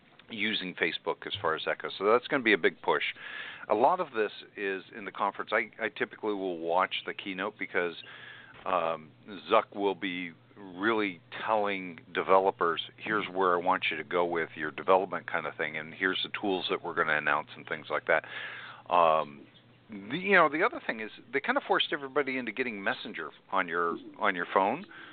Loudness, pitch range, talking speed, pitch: -30 LUFS, 80-110 Hz, 200 wpm, 95 Hz